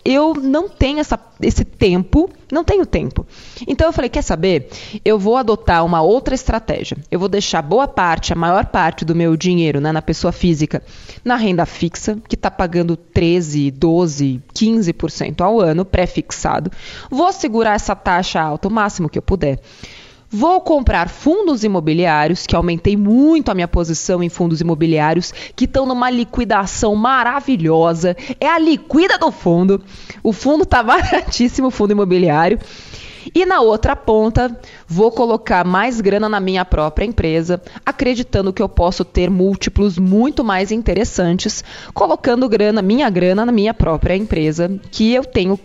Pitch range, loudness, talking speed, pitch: 170-245 Hz, -16 LUFS, 155 wpm, 200 Hz